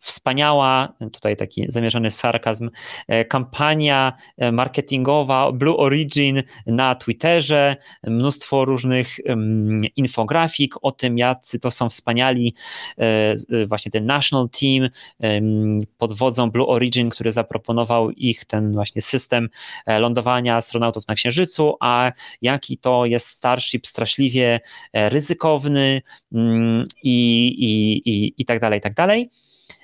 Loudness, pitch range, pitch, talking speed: -19 LUFS, 115-135 Hz, 120 Hz, 110 wpm